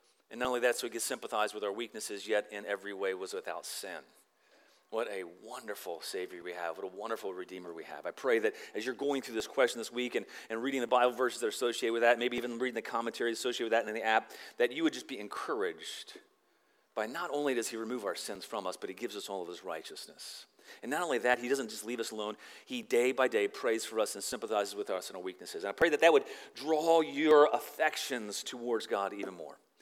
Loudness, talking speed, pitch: -33 LUFS, 250 wpm, 145 Hz